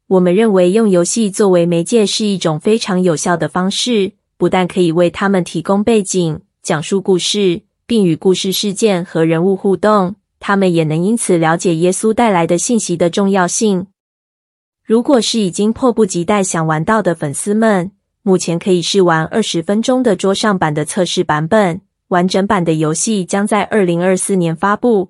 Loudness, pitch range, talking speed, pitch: -14 LUFS, 175-210 Hz, 275 characters per minute, 190 Hz